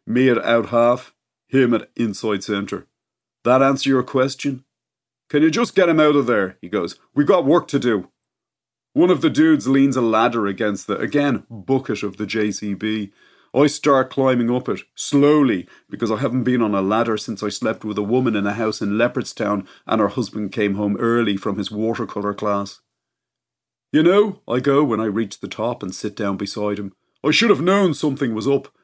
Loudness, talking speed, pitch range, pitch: -19 LUFS, 200 wpm, 105-135 Hz, 115 Hz